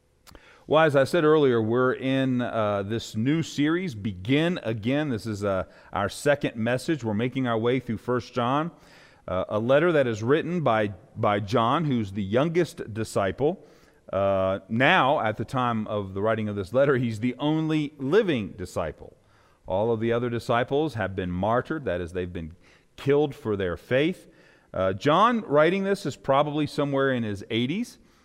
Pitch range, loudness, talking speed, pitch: 110-145 Hz, -25 LUFS, 170 wpm, 125 Hz